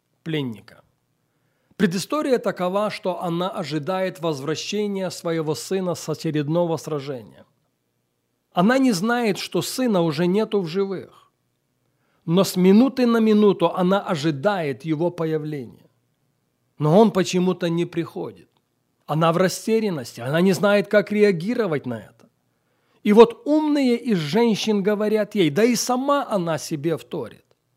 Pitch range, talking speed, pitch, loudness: 160-210 Hz, 125 wpm, 185 Hz, -21 LUFS